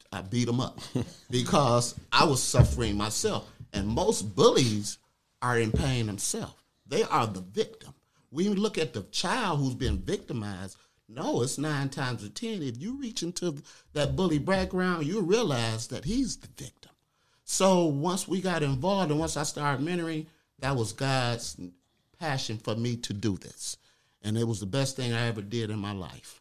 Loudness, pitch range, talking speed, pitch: -29 LUFS, 115-160 Hz, 175 wpm, 135 Hz